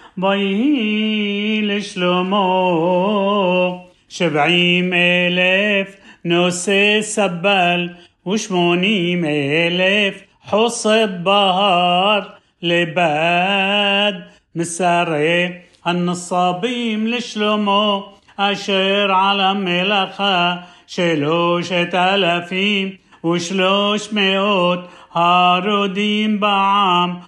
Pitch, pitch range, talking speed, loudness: 190 Hz, 175-205 Hz, 50 wpm, -16 LUFS